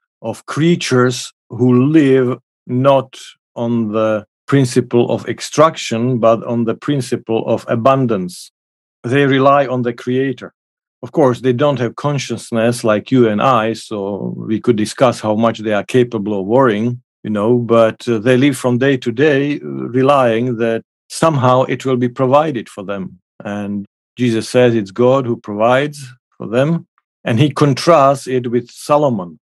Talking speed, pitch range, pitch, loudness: 155 wpm, 115-135 Hz, 125 Hz, -15 LUFS